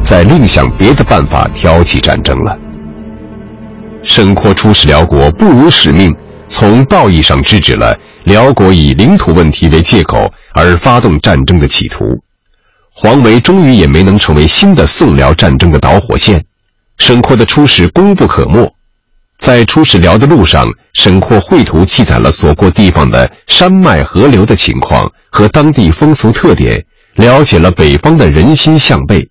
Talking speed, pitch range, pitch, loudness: 240 characters per minute, 80-120 Hz, 100 Hz, -6 LUFS